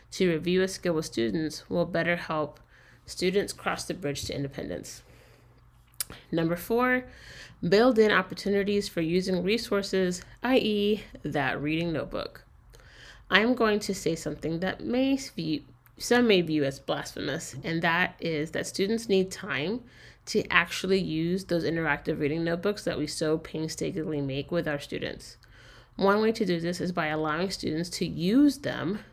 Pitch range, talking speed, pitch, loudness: 150-200 Hz, 155 wpm, 170 Hz, -28 LUFS